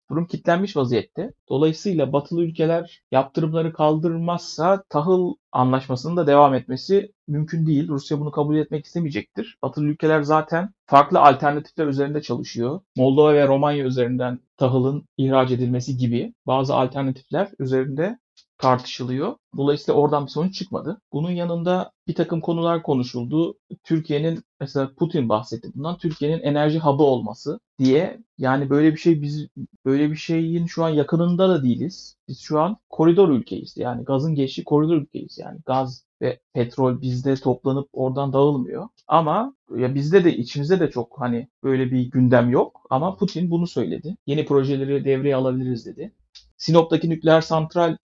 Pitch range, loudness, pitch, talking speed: 130-165 Hz, -21 LUFS, 150 Hz, 145 wpm